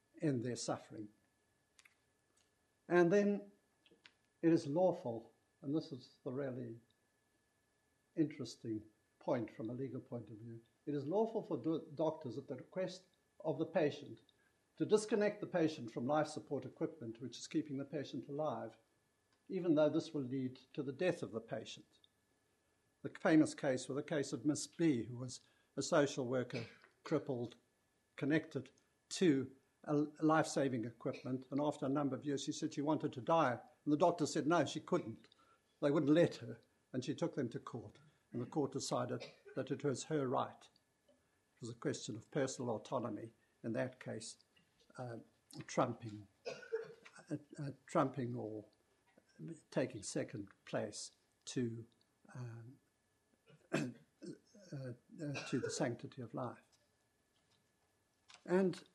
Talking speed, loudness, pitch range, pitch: 150 wpm, -40 LUFS, 120-155 Hz, 140 Hz